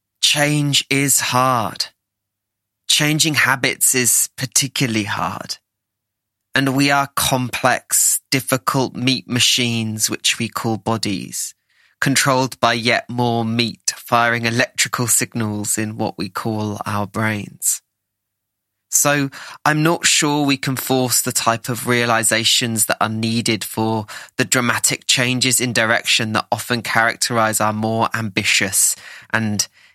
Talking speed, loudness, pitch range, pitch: 120 wpm, -17 LUFS, 110-130 Hz, 115 Hz